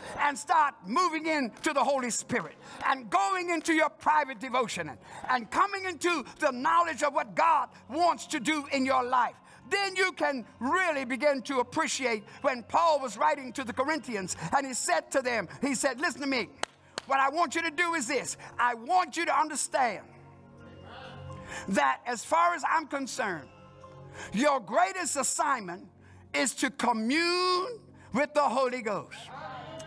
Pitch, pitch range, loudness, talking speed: 285 Hz, 255-330 Hz, -28 LUFS, 160 wpm